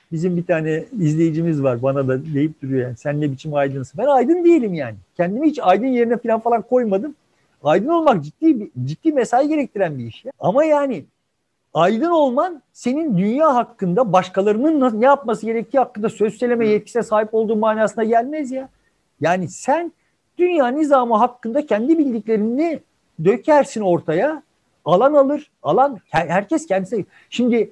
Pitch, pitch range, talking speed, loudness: 225 Hz, 180-275 Hz, 150 wpm, -18 LUFS